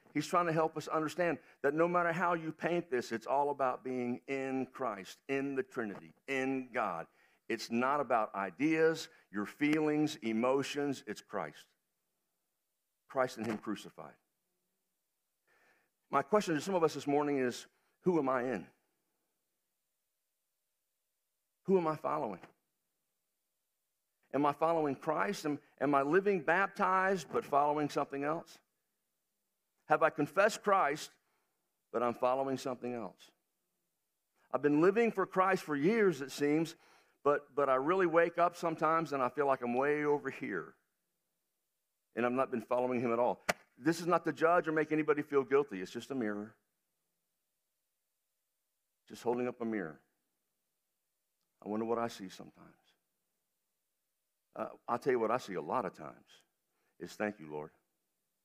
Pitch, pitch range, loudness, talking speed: 135 Hz, 115-160 Hz, -34 LUFS, 150 wpm